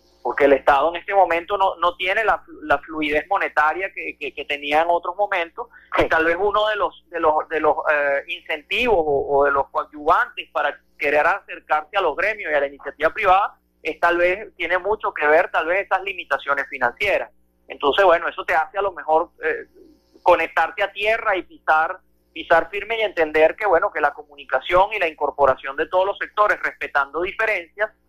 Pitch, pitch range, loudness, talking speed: 165 Hz, 150-195 Hz, -20 LUFS, 195 wpm